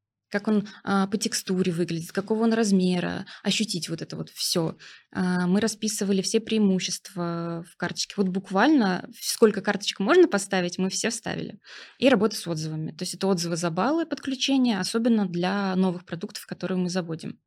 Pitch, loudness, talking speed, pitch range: 195 Hz, -25 LUFS, 165 wpm, 180-220 Hz